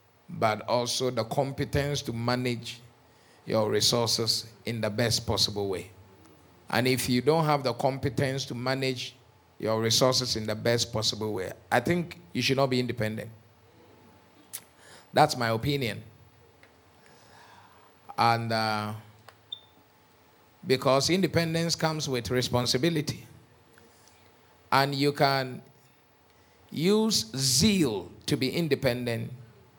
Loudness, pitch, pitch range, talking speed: -27 LUFS, 120 Hz, 110-135 Hz, 110 wpm